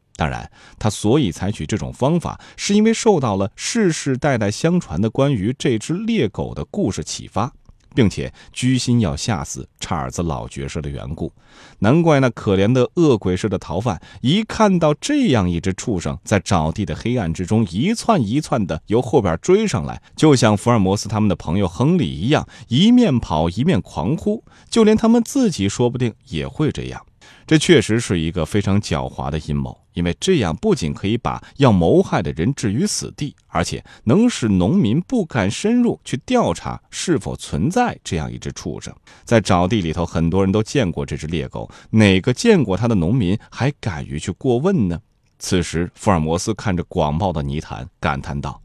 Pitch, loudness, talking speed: 105 Hz, -19 LUFS, 280 characters per minute